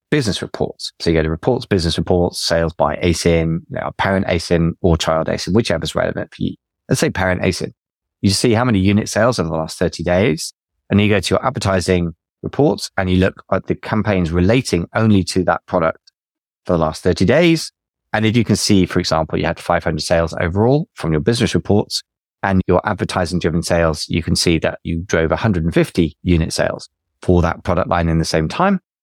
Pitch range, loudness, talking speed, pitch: 85-105 Hz, -17 LUFS, 215 wpm, 90 Hz